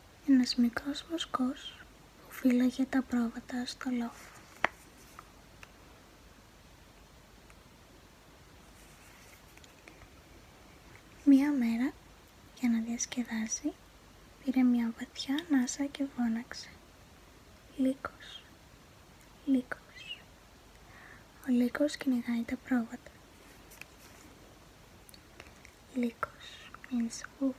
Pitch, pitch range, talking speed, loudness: 255 Hz, 240-275 Hz, 65 wpm, -33 LUFS